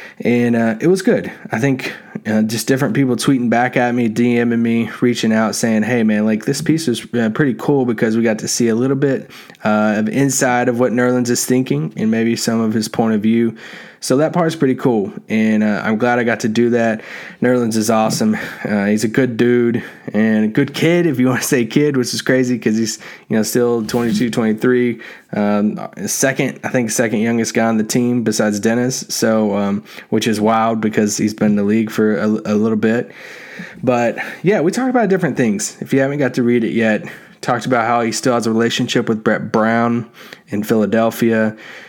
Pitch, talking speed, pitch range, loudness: 115 Hz, 215 wpm, 110-125 Hz, -16 LUFS